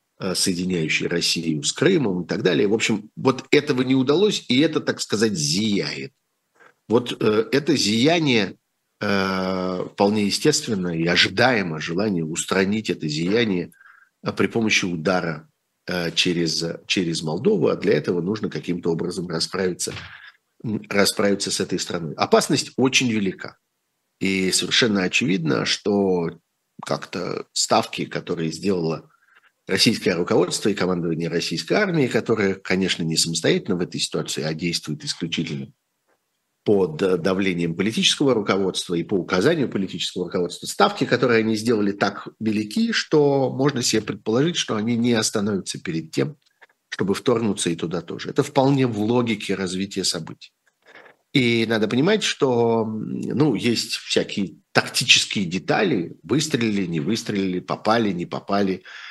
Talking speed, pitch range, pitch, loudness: 125 wpm, 85-115 Hz, 95 Hz, -21 LUFS